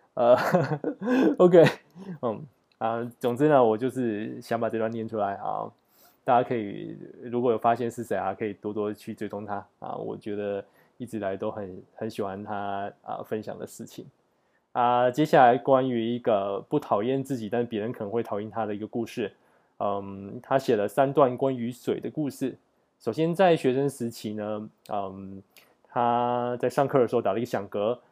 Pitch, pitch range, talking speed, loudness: 115 Hz, 105-135 Hz, 285 characters per minute, -26 LUFS